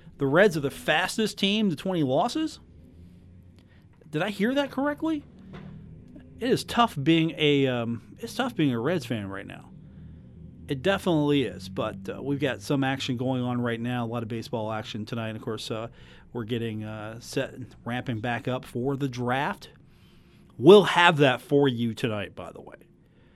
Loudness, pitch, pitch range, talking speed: -26 LUFS, 130 Hz, 115-160 Hz, 180 wpm